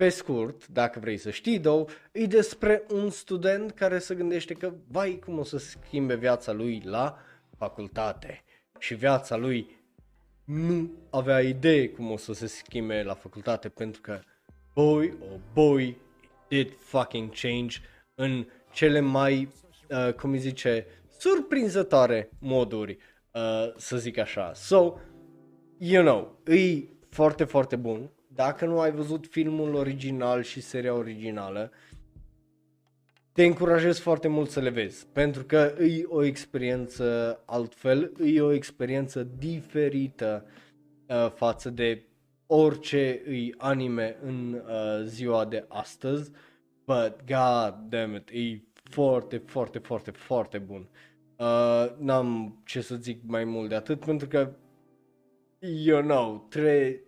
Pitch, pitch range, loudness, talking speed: 130 Hz, 115-150 Hz, -27 LUFS, 135 wpm